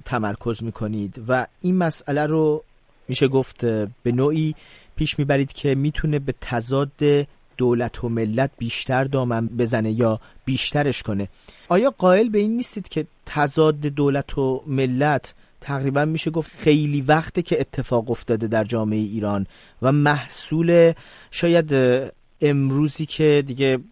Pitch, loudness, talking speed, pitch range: 135 Hz, -21 LUFS, 130 wpm, 120-150 Hz